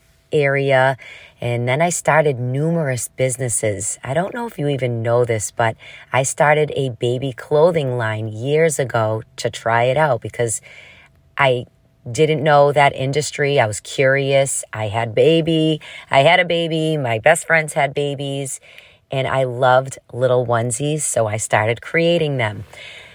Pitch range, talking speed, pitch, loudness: 120-150 Hz, 155 wpm, 135 Hz, -18 LUFS